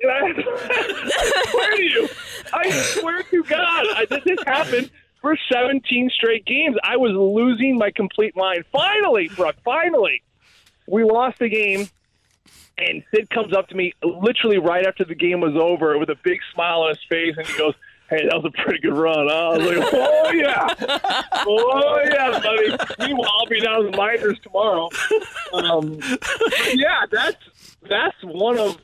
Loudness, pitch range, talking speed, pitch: -19 LUFS, 185-295 Hz, 170 wpm, 225 Hz